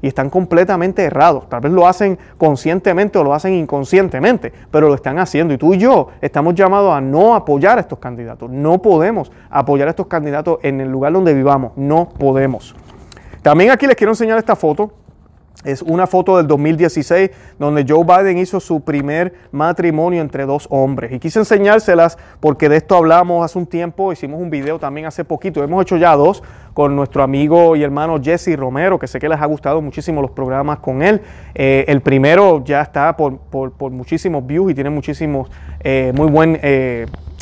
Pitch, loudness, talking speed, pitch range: 155 Hz, -14 LUFS, 190 wpm, 140-180 Hz